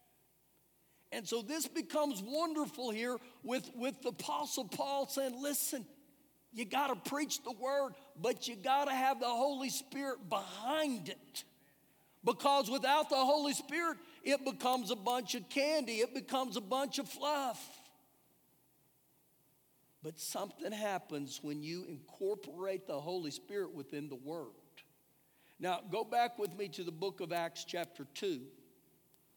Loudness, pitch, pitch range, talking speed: -38 LUFS, 255 Hz, 195-280 Hz, 140 wpm